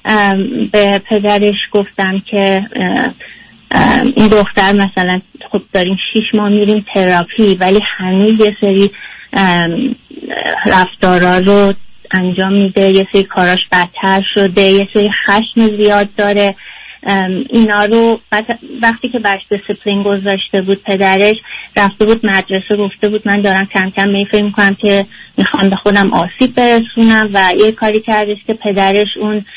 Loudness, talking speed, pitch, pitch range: -11 LUFS, 130 wpm, 205 Hz, 195-215 Hz